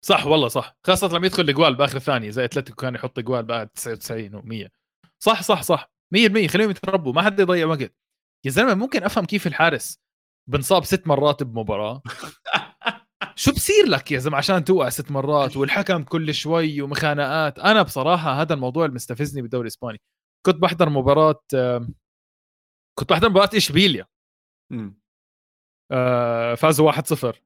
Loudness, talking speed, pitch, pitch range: -20 LUFS, 145 wpm, 145 Hz, 125-180 Hz